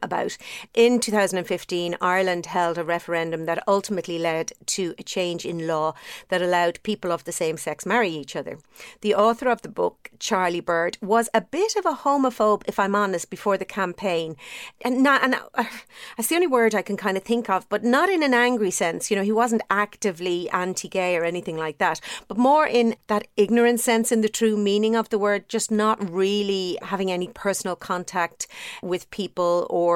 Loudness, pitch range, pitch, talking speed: -23 LUFS, 180-230 Hz, 200 Hz, 195 wpm